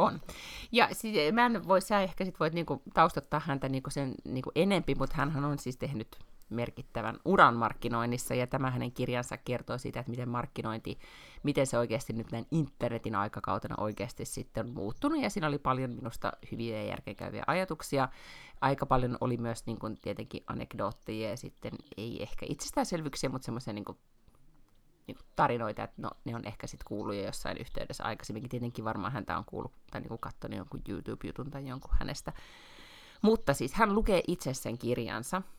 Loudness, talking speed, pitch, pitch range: -33 LUFS, 170 wpm, 130 Hz, 115-145 Hz